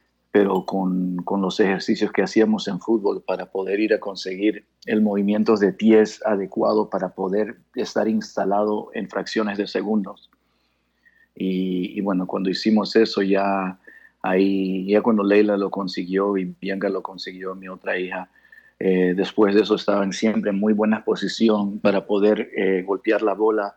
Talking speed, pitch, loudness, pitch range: 160 wpm, 100 Hz, -21 LUFS, 95-105 Hz